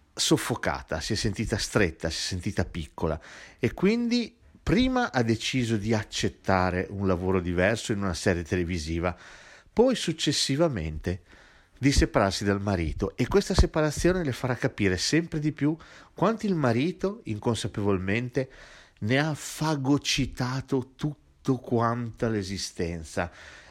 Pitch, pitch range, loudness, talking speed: 115 Hz, 95-150 Hz, -27 LUFS, 120 wpm